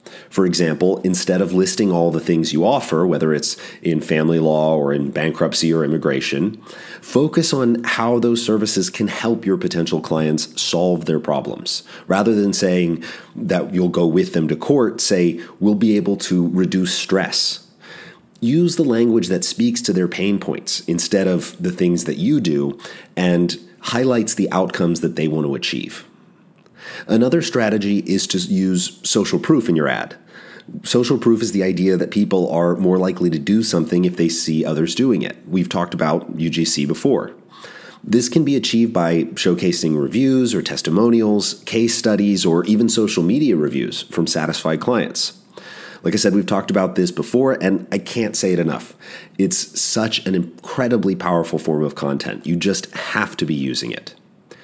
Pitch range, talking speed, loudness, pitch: 85-110 Hz, 170 wpm, -18 LUFS, 90 Hz